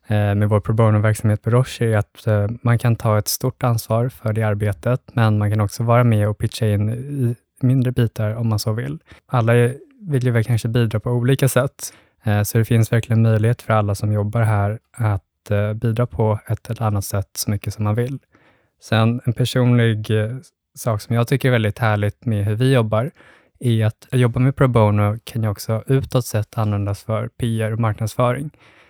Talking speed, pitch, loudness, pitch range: 195 wpm, 115 Hz, -19 LUFS, 105-120 Hz